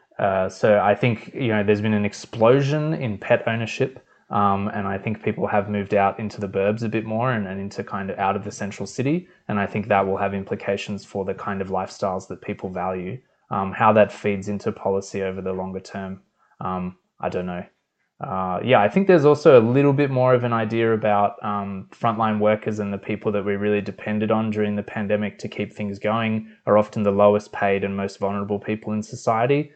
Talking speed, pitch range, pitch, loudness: 220 wpm, 100-110 Hz, 105 Hz, -22 LUFS